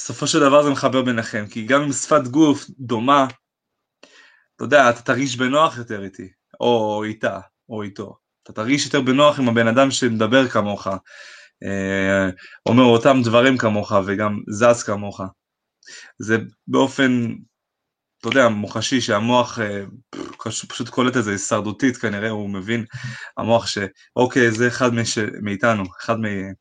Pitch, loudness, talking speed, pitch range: 115 Hz, -19 LUFS, 140 wpm, 105-130 Hz